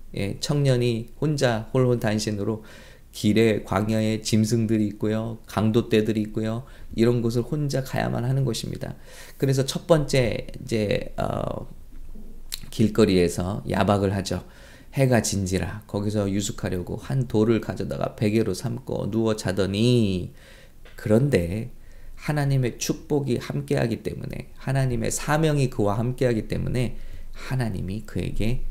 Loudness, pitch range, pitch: -24 LUFS, 105-130 Hz, 115 Hz